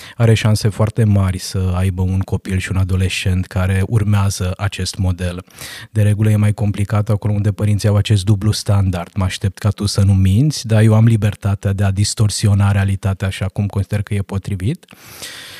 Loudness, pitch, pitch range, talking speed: -17 LUFS, 100 Hz, 95-105 Hz, 185 wpm